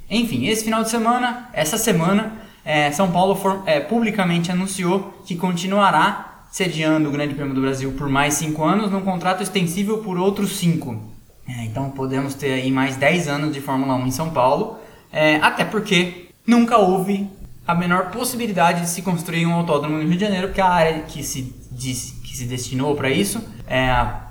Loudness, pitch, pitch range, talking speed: -20 LUFS, 170 Hz, 140-195 Hz, 190 wpm